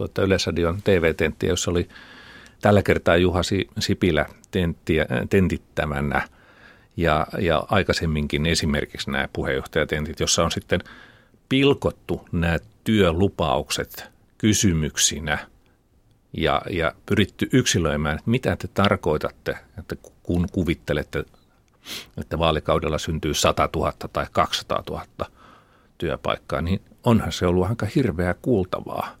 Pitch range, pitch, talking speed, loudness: 80-100 Hz, 90 Hz, 105 wpm, -23 LUFS